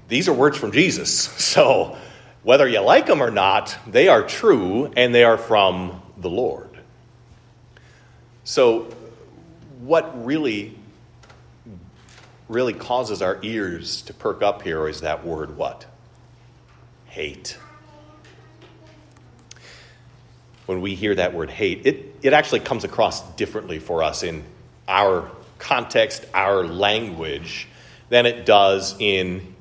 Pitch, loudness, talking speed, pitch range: 115 Hz, -19 LUFS, 120 wpm, 95-120 Hz